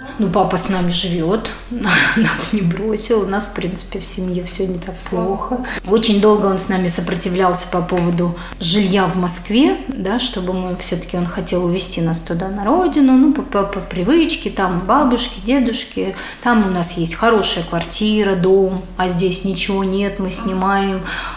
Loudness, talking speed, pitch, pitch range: -17 LUFS, 165 wpm, 195 Hz, 180-215 Hz